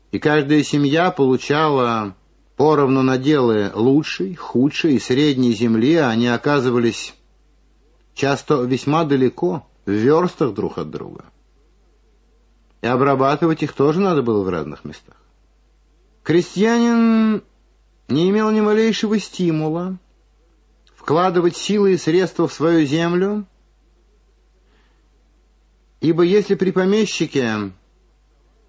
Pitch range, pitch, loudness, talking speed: 130-185 Hz, 155 Hz, -18 LUFS, 100 wpm